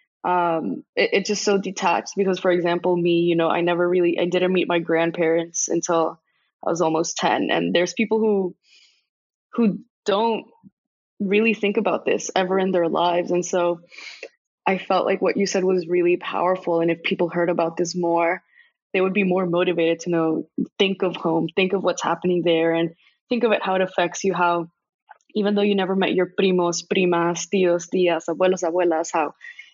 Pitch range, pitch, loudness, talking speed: 170-195 Hz, 180 Hz, -21 LUFS, 190 wpm